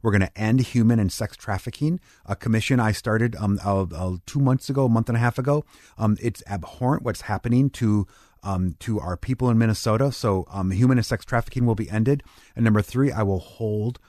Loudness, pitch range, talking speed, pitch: -23 LUFS, 100-125 Hz, 215 wpm, 115 Hz